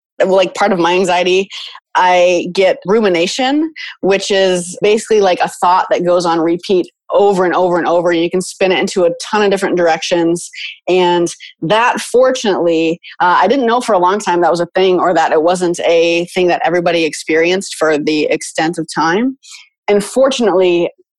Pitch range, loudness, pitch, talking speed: 170-200 Hz, -13 LUFS, 180 Hz, 185 wpm